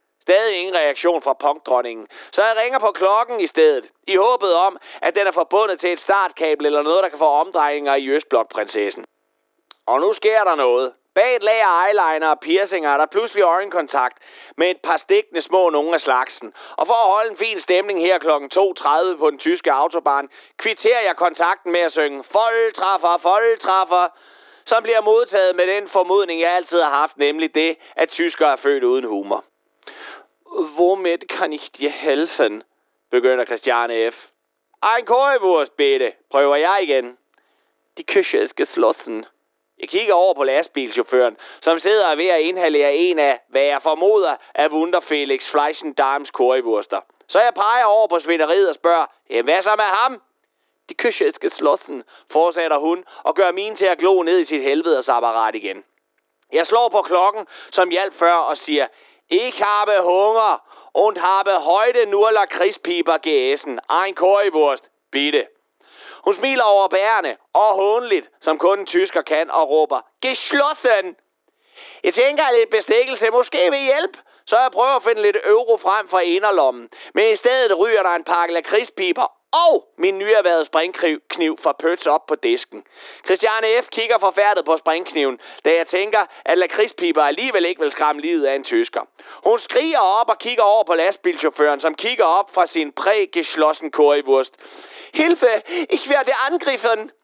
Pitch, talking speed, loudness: 195 Hz, 165 wpm, -18 LUFS